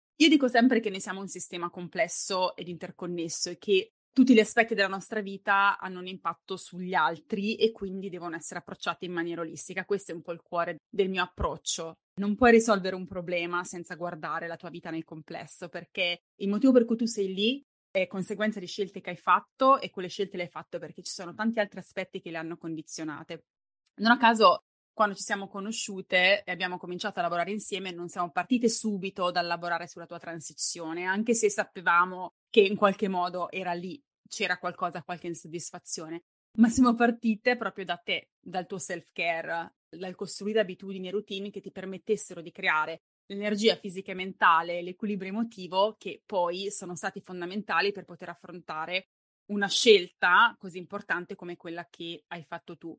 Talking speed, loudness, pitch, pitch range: 185 wpm, -28 LUFS, 185 Hz, 175-205 Hz